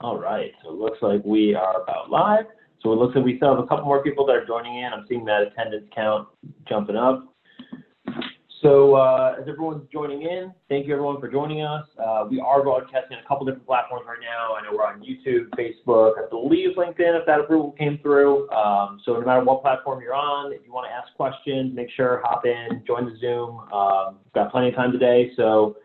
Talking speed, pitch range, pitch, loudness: 230 wpm, 115-145 Hz, 130 Hz, -22 LUFS